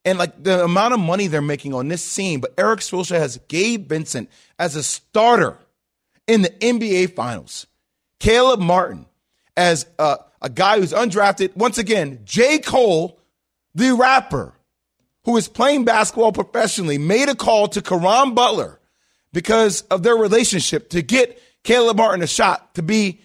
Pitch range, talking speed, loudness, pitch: 175-230 Hz, 155 wpm, -17 LUFS, 200 Hz